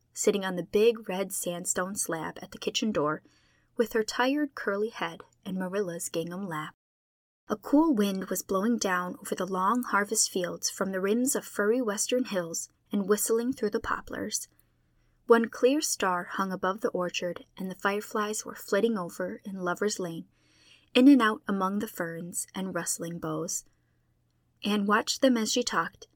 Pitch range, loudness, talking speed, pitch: 180-230 Hz, -29 LUFS, 170 wpm, 200 Hz